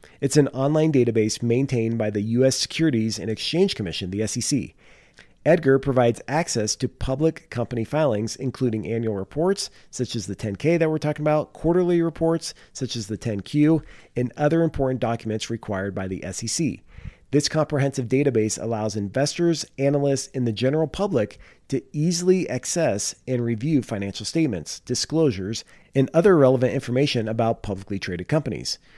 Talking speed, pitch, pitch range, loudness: 150 wpm, 130 Hz, 110-150 Hz, -23 LUFS